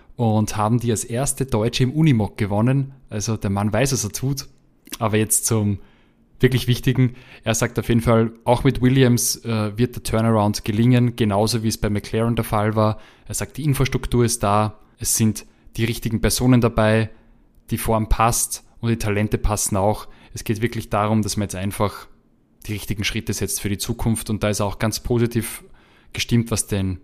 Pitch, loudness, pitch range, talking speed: 110 Hz, -21 LUFS, 105-120 Hz, 190 wpm